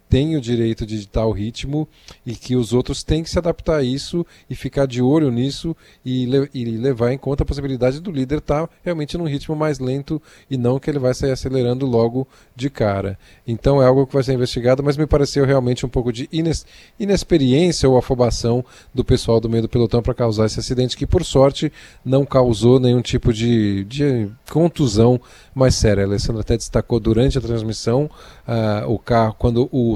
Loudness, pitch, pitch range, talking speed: -19 LUFS, 130 Hz, 115-140 Hz, 200 wpm